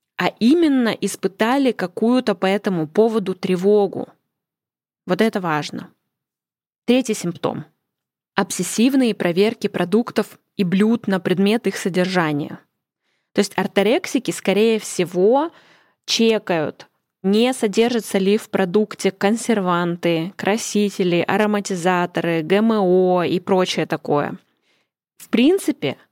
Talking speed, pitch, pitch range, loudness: 95 wpm, 200 Hz, 185-220 Hz, -19 LUFS